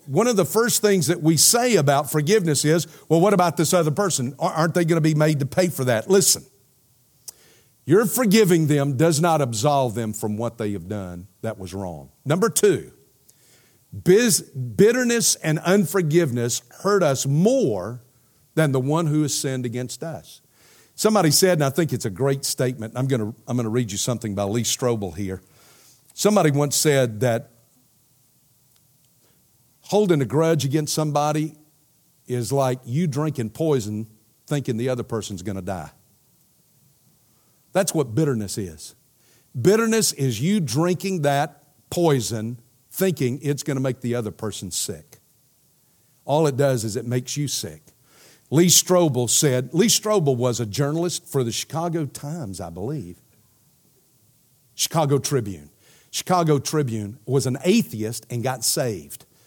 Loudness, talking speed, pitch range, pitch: -21 LUFS, 155 wpm, 120-160 Hz, 140 Hz